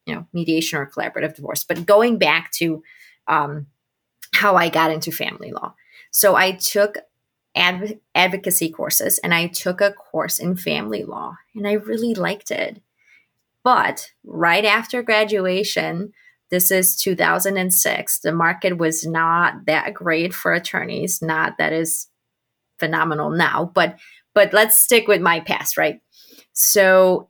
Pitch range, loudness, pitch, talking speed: 165-205 Hz, -18 LUFS, 180 Hz, 145 wpm